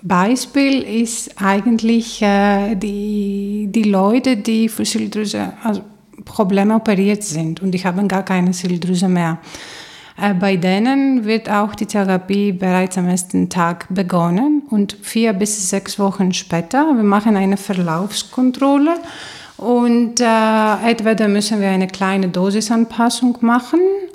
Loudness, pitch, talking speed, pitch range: -16 LUFS, 205 Hz, 130 wpm, 190-230 Hz